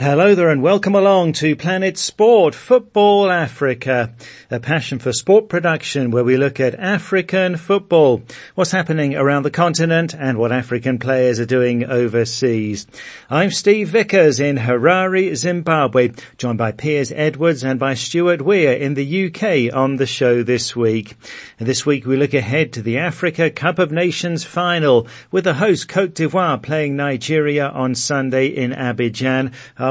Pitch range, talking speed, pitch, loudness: 130-175 Hz, 160 wpm, 145 Hz, -16 LUFS